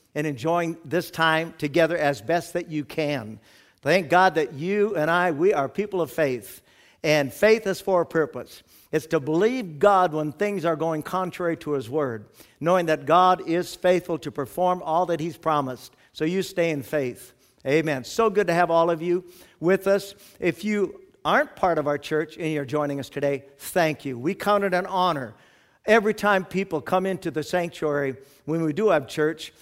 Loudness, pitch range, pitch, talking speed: -24 LUFS, 150-180 Hz, 165 Hz, 195 wpm